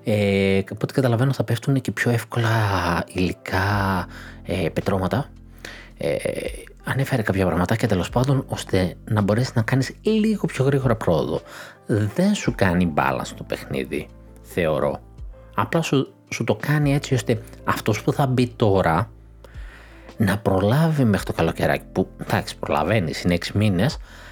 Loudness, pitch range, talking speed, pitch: -22 LUFS, 95-135 Hz, 140 wpm, 110 Hz